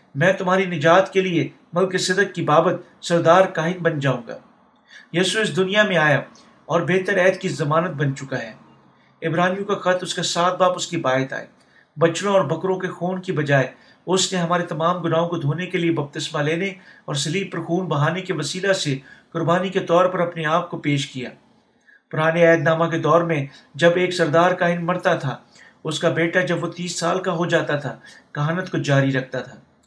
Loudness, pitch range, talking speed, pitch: -20 LUFS, 155-185 Hz, 205 wpm, 170 Hz